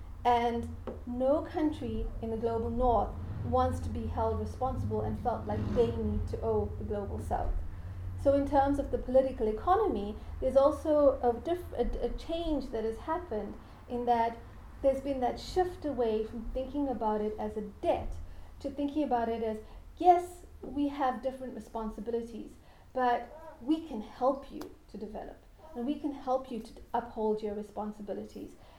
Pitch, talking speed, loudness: 235 Hz, 165 wpm, -32 LUFS